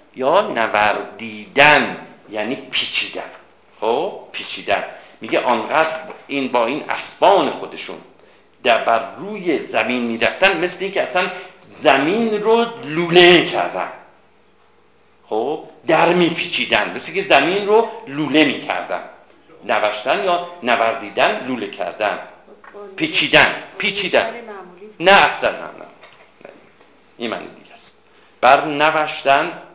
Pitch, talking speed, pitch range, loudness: 170 Hz, 100 wpm, 140-195 Hz, -17 LUFS